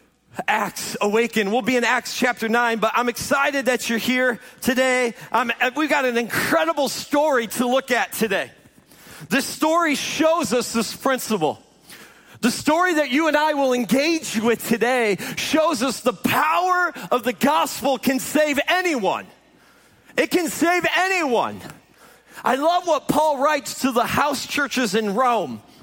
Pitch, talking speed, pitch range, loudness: 255 Hz, 155 wpm, 235-300 Hz, -20 LUFS